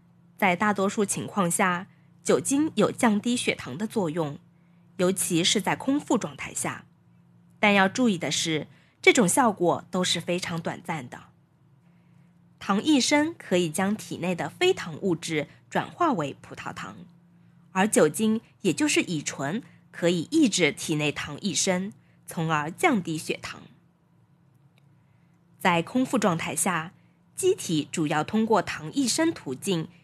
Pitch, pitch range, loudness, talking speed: 175 Hz, 160-215 Hz, -25 LUFS, 205 characters per minute